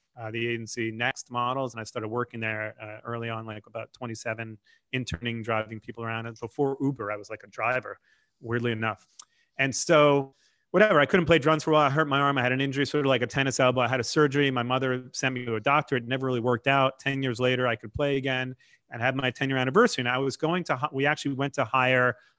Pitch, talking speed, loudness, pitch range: 130 Hz, 250 wpm, -26 LUFS, 115-140 Hz